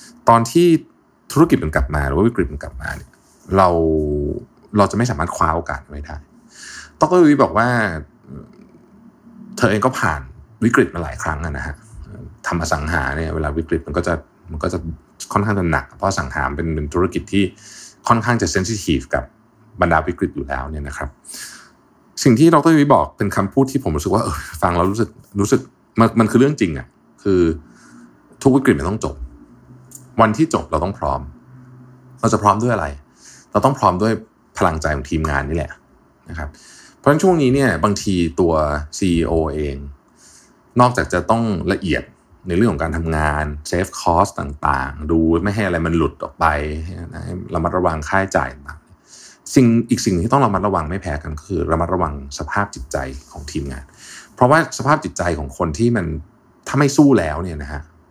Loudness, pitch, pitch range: -18 LUFS, 90 Hz, 75-115 Hz